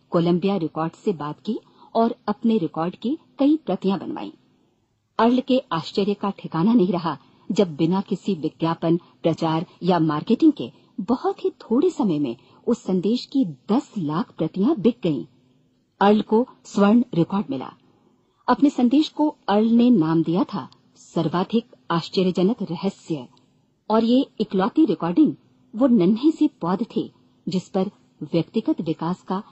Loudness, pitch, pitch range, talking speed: -22 LUFS, 195 Hz, 165-235 Hz, 140 wpm